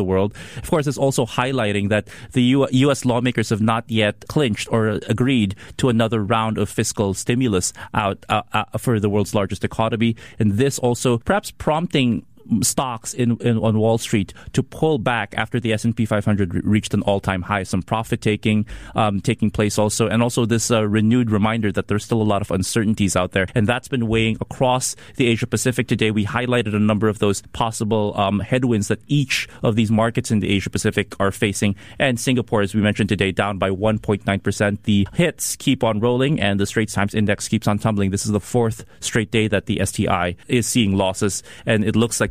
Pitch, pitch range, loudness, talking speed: 110 Hz, 105-120 Hz, -20 LUFS, 210 wpm